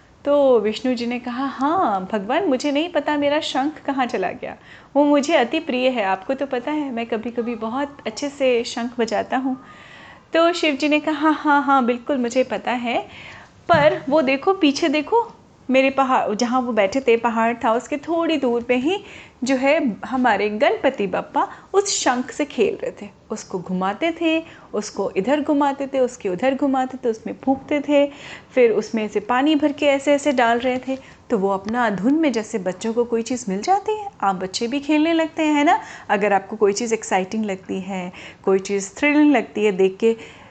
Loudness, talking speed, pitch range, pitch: -20 LUFS, 195 wpm, 230-295 Hz, 260 Hz